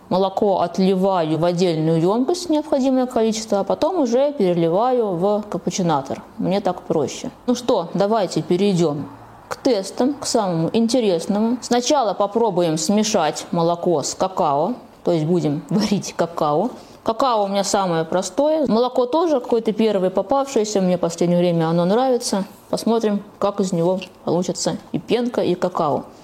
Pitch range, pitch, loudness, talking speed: 175-235 Hz, 200 Hz, -20 LUFS, 140 wpm